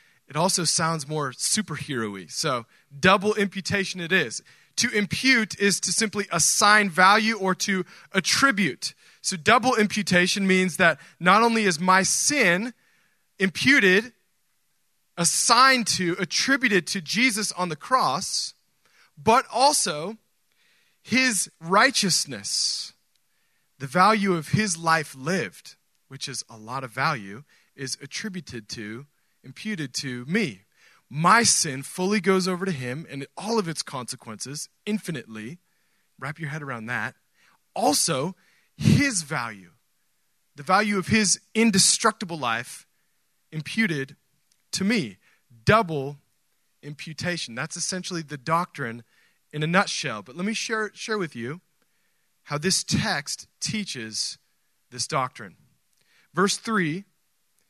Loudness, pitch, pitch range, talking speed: -23 LUFS, 180 Hz, 145-205 Hz, 120 wpm